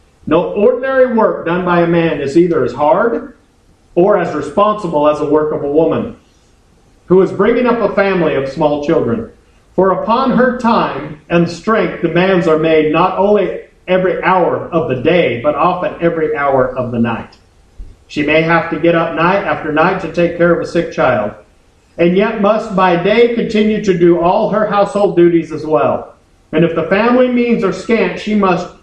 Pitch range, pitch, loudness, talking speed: 155-205 Hz, 175 Hz, -13 LUFS, 190 wpm